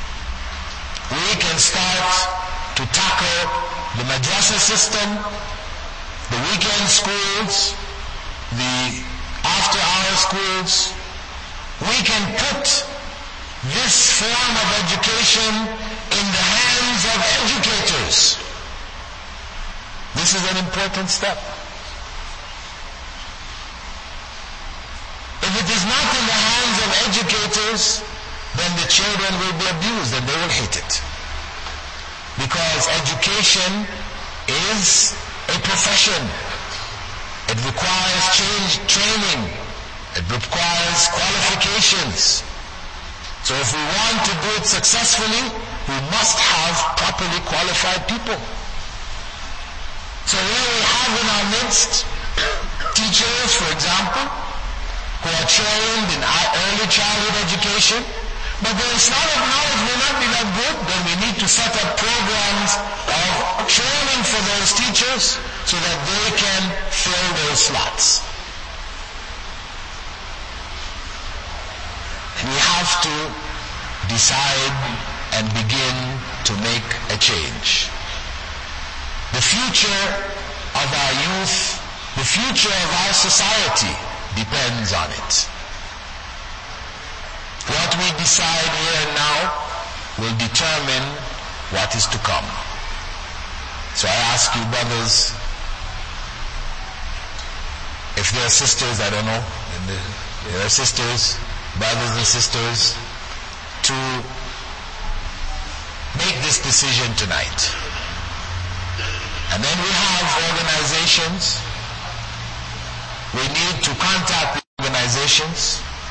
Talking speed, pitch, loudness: 100 wpm, 125 Hz, -17 LUFS